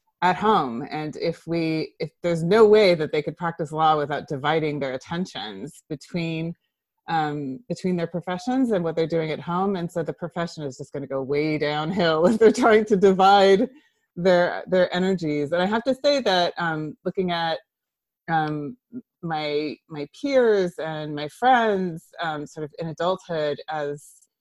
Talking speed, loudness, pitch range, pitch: 170 wpm, -23 LUFS, 155-190 Hz, 170 Hz